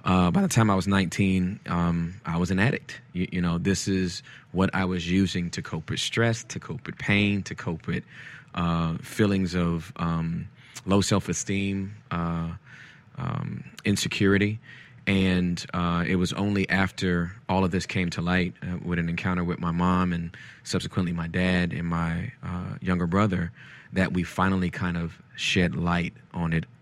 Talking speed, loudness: 175 wpm, -26 LUFS